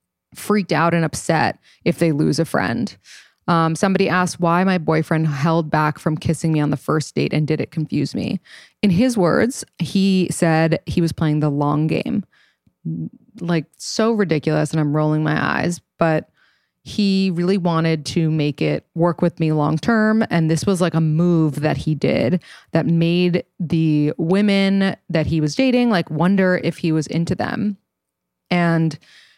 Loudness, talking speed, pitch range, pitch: -19 LUFS, 175 wpm, 155-185 Hz, 165 Hz